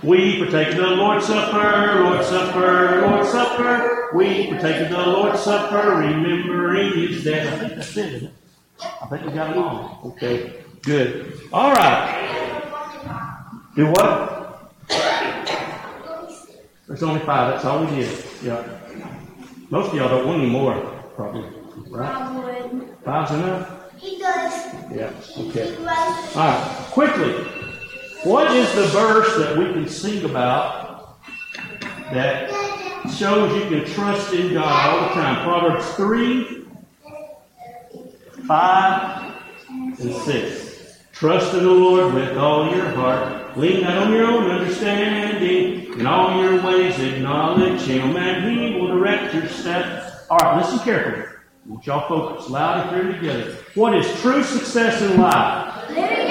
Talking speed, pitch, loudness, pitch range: 135 wpm, 185 Hz, -19 LUFS, 160-215 Hz